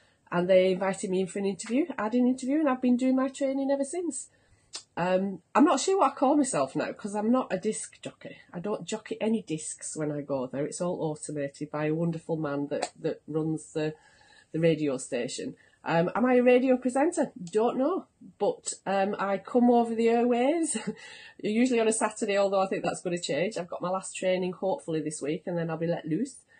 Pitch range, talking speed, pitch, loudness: 165-255 Hz, 220 wpm, 205 Hz, -28 LUFS